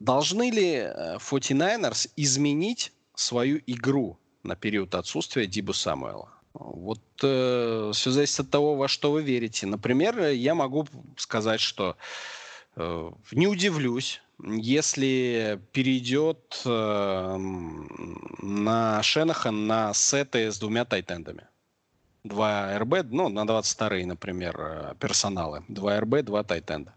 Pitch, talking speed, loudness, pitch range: 115 Hz, 110 wpm, -26 LUFS, 105-140 Hz